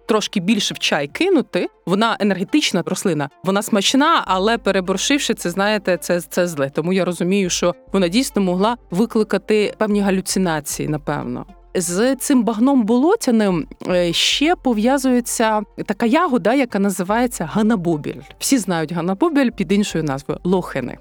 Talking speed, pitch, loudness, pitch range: 130 wpm, 200 Hz, -18 LUFS, 180-235 Hz